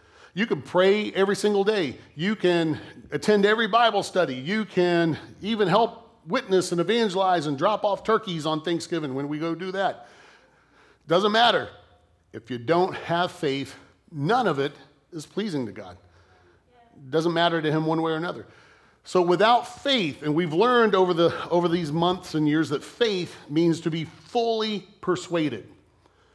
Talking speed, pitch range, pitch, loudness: 165 wpm, 150-205 Hz, 170 Hz, -24 LUFS